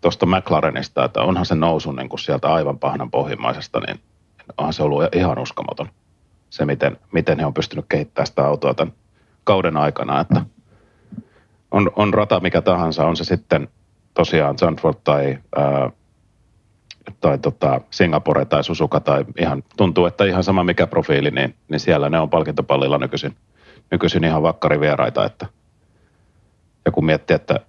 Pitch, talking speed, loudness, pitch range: 85 Hz, 150 wpm, -19 LUFS, 75-95 Hz